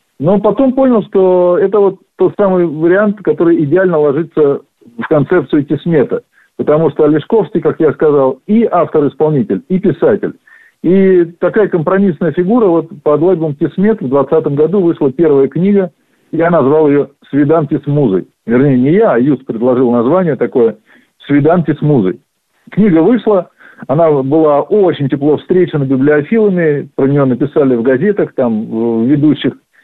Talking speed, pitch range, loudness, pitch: 145 wpm, 140-185 Hz, -11 LUFS, 160 Hz